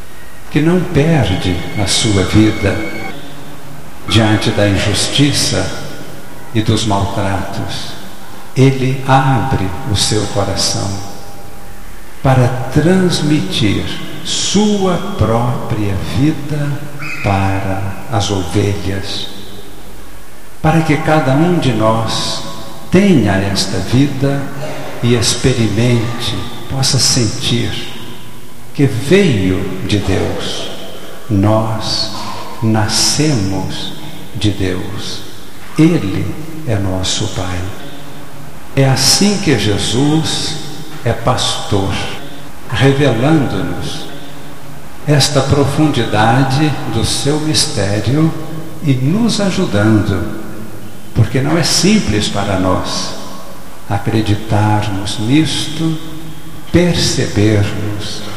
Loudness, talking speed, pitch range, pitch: -14 LUFS, 75 wpm, 100-145 Hz, 115 Hz